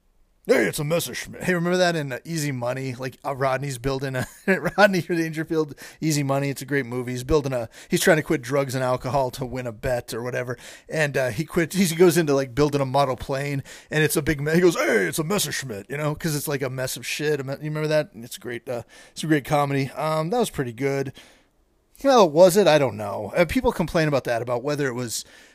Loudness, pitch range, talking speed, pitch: -23 LUFS, 130-165 Hz, 240 wpm, 145 Hz